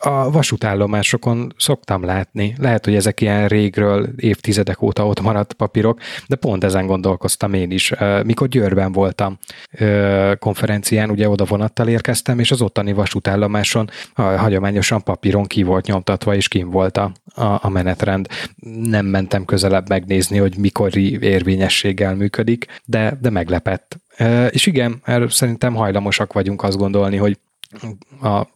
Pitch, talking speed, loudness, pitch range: 100 Hz, 130 wpm, -17 LUFS, 100-115 Hz